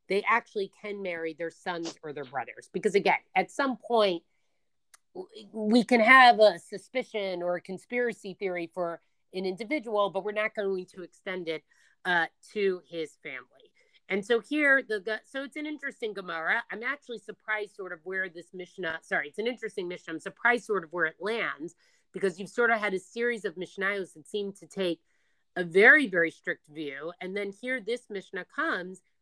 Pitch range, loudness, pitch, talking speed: 180-225 Hz, -28 LUFS, 195 Hz, 185 wpm